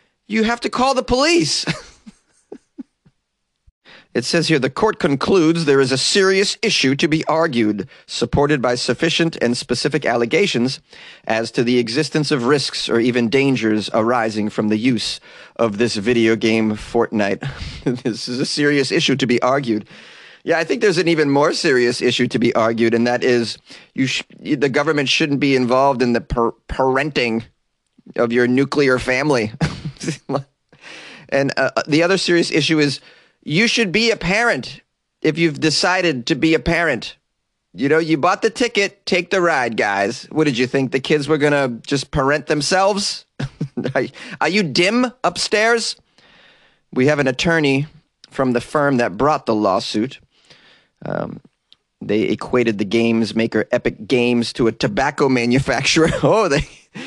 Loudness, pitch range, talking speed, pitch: -17 LUFS, 120-160 Hz, 160 wpm, 140 Hz